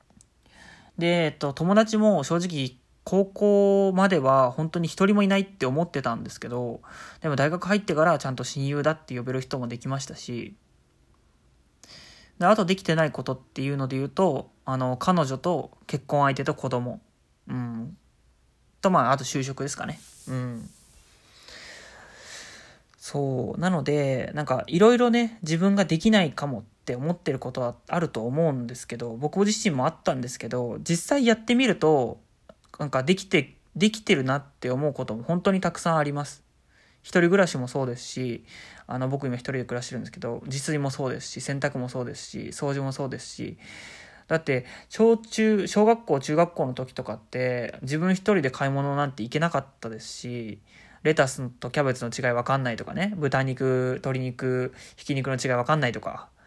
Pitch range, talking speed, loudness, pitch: 125-170 Hz, 350 characters per minute, -25 LUFS, 140 Hz